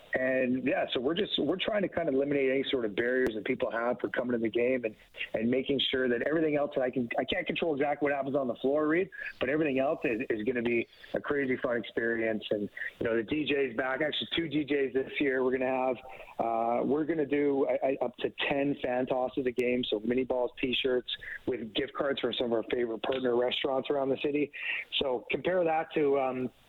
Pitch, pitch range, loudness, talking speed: 130 Hz, 125-140 Hz, -30 LUFS, 240 wpm